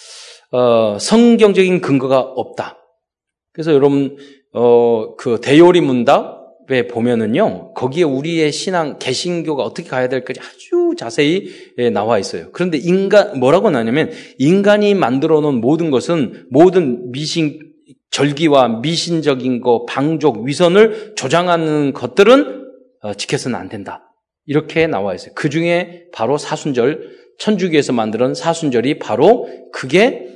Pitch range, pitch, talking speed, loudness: 130-180 Hz, 155 Hz, 285 characters per minute, -15 LUFS